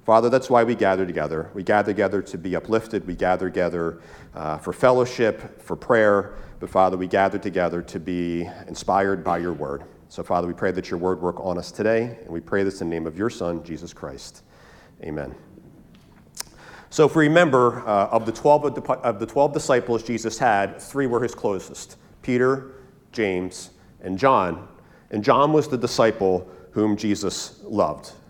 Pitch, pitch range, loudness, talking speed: 100 Hz, 90-120 Hz, -22 LUFS, 180 wpm